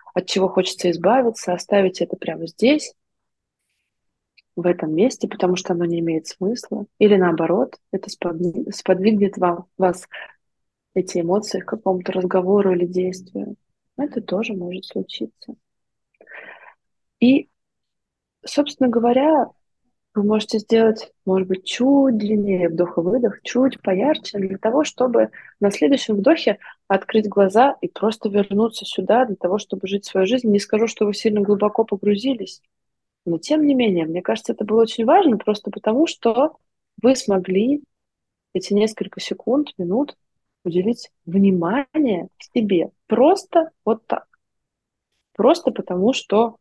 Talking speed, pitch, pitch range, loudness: 130 wpm, 205 Hz, 185-240 Hz, -20 LUFS